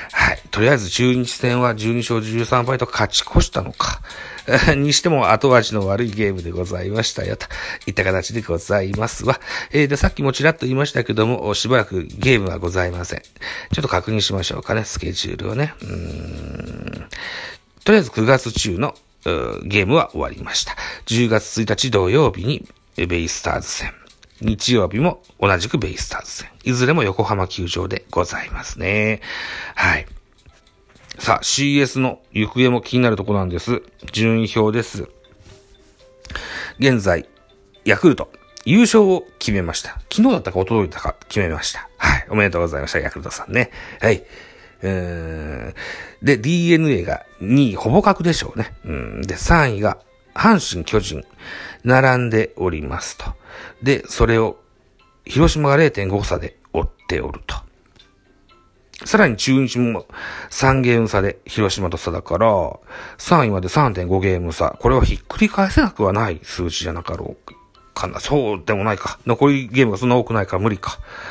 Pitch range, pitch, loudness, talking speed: 95-130 Hz, 110 Hz, -18 LUFS, 310 characters per minute